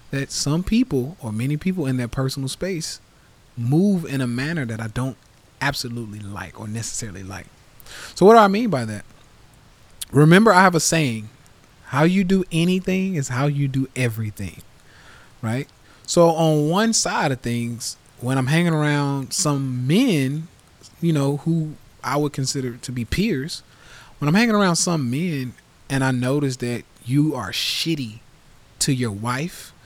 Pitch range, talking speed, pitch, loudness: 120-160 Hz, 165 wpm, 135 Hz, -21 LUFS